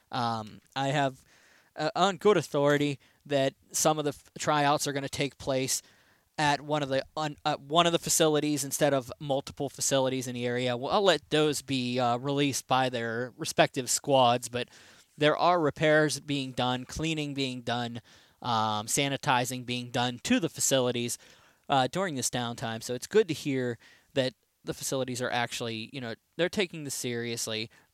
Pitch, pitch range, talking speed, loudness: 135 Hz, 125-150 Hz, 175 wpm, -29 LUFS